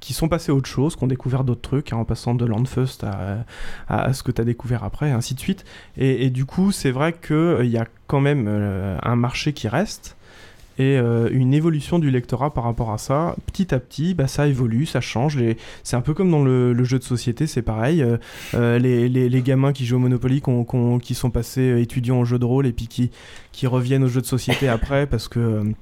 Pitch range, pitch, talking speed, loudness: 120-135 Hz, 125 Hz, 260 wpm, -21 LUFS